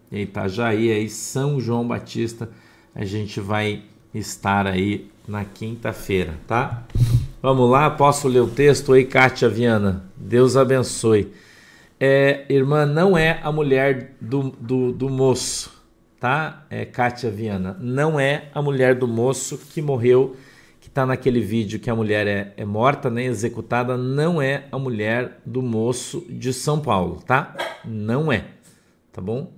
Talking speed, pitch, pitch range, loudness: 150 wpm, 120 Hz, 110-135 Hz, -20 LUFS